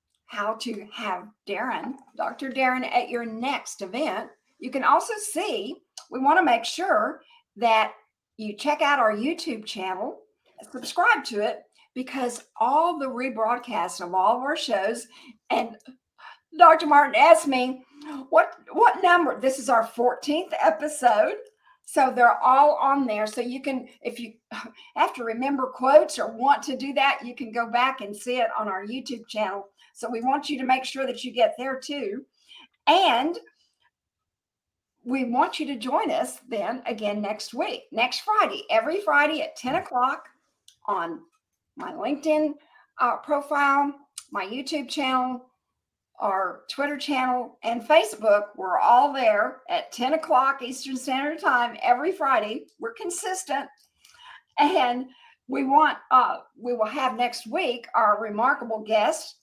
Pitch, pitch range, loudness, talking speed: 270 Hz, 240-315 Hz, -24 LUFS, 150 wpm